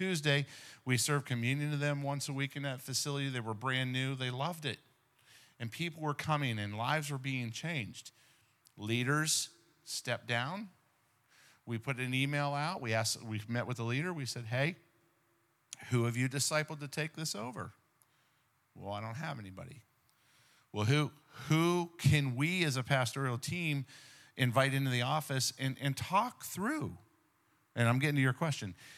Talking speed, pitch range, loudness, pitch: 170 wpm, 120-150 Hz, -35 LUFS, 135 Hz